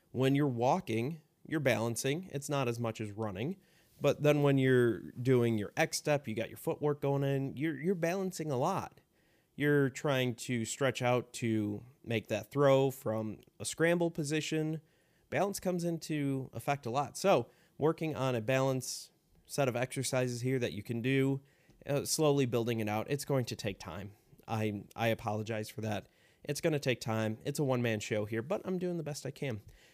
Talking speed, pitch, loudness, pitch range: 190 wpm, 135 Hz, -33 LUFS, 115-150 Hz